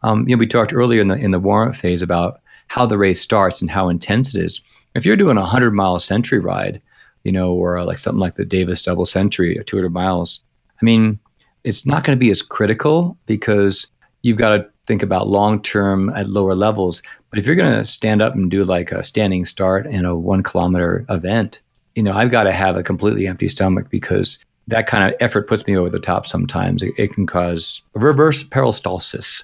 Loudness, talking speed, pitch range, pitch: -17 LUFS, 215 wpm, 95-115 Hz, 100 Hz